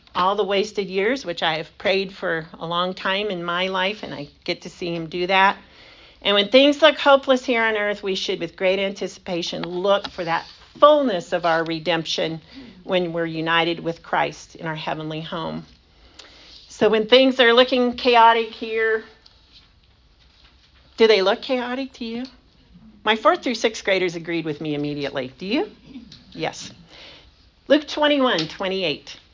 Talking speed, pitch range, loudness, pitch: 170 wpm, 165-230 Hz, -20 LUFS, 190 Hz